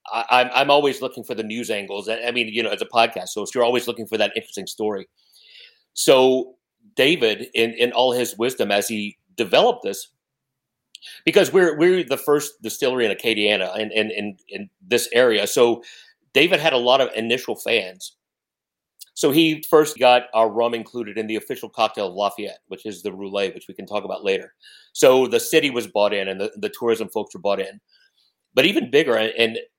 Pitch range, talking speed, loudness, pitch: 110-155 Hz, 200 wpm, -20 LUFS, 120 Hz